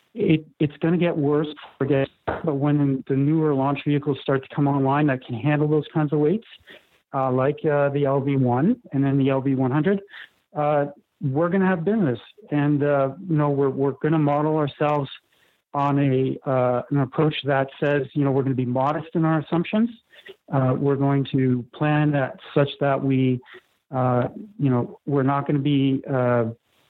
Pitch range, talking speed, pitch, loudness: 135-155 Hz, 185 wpm, 145 Hz, -22 LUFS